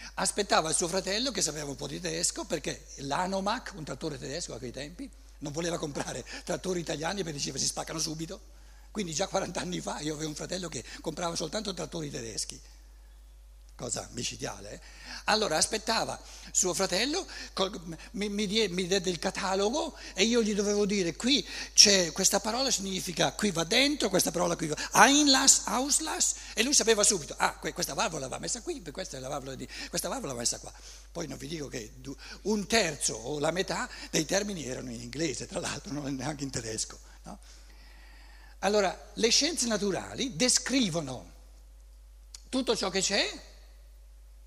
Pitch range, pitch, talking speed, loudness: 140-210 Hz, 180 Hz, 175 wpm, -29 LUFS